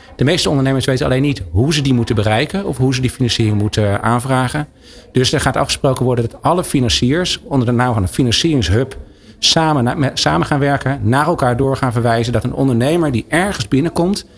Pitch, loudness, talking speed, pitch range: 130 Hz, -15 LUFS, 195 wpm, 120-145 Hz